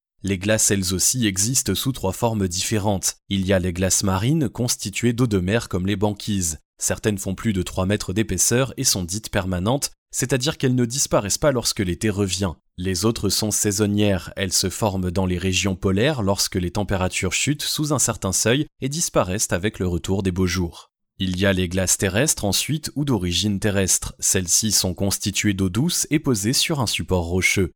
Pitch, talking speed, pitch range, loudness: 100 Hz, 190 wpm, 95-115 Hz, -21 LUFS